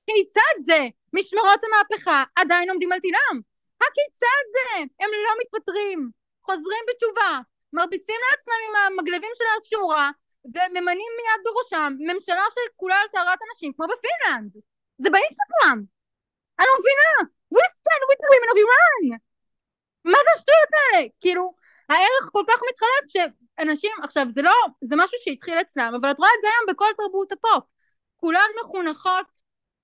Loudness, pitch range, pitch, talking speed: -20 LUFS, 310-435 Hz, 370 Hz, 140 wpm